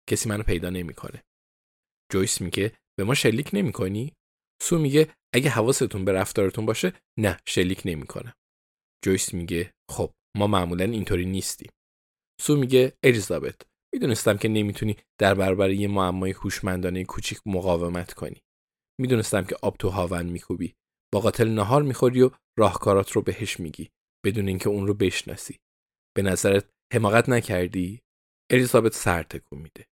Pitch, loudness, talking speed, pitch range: 100 Hz, -24 LUFS, 135 wpm, 90-115 Hz